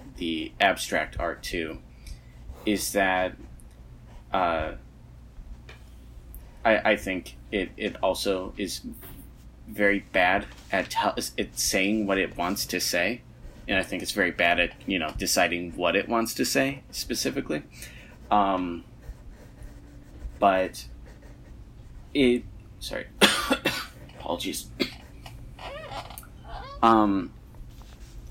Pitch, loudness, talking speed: 85 Hz, -26 LUFS, 100 wpm